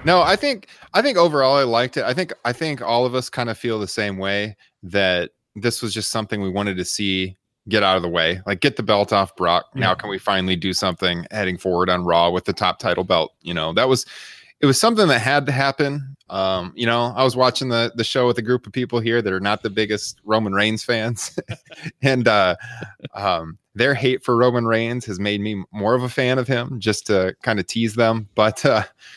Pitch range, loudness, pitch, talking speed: 100-125 Hz, -20 LUFS, 115 Hz, 240 wpm